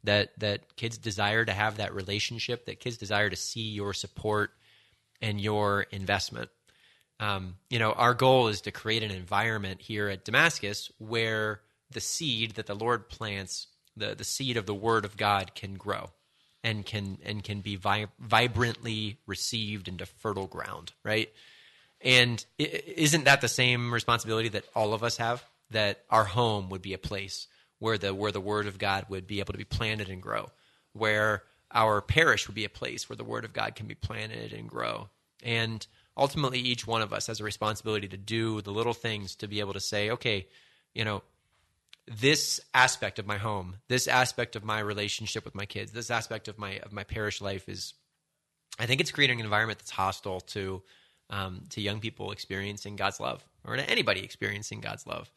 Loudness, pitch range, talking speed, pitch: -29 LUFS, 100-115 Hz, 190 wpm, 105 Hz